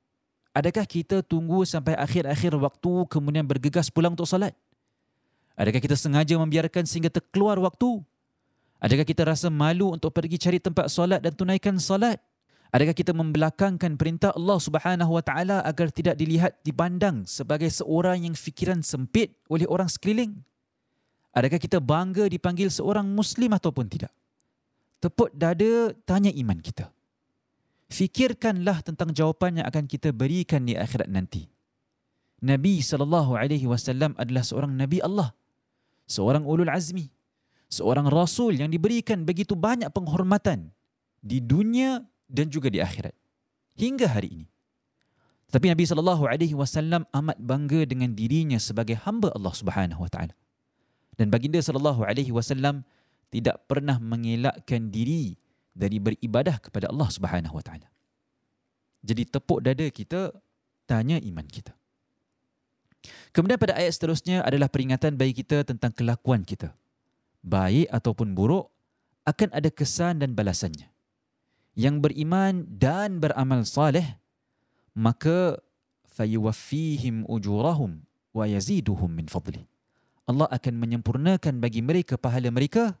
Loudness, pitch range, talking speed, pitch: -25 LUFS, 125-180 Hz, 125 wpm, 155 Hz